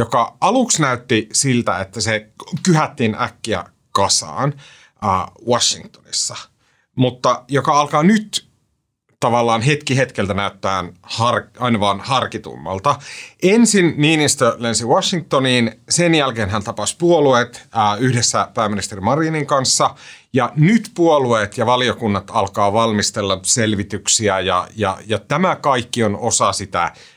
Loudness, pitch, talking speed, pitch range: -17 LUFS, 120 Hz, 110 wpm, 105-145 Hz